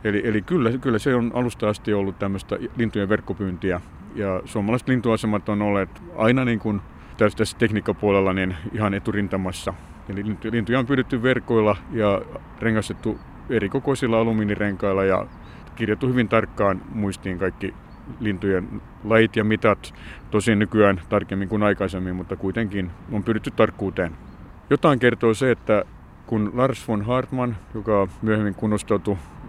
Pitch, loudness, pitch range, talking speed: 105 Hz, -23 LUFS, 95-115 Hz, 135 wpm